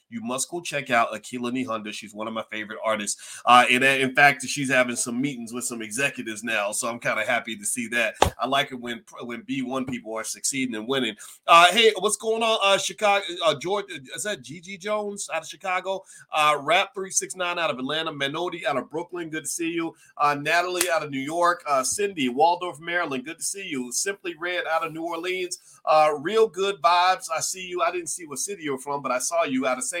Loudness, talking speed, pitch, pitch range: -24 LUFS, 235 wpm, 160 Hz, 125-185 Hz